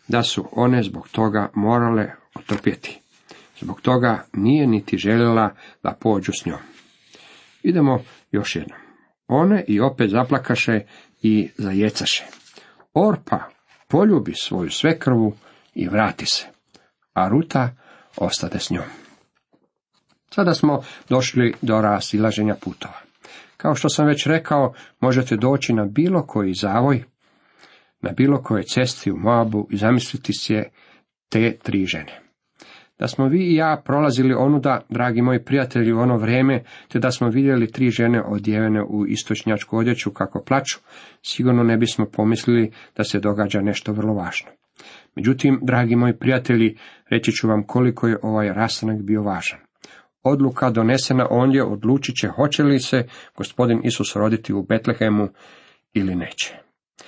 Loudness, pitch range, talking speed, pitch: -20 LUFS, 105-130 Hz, 135 wpm, 115 Hz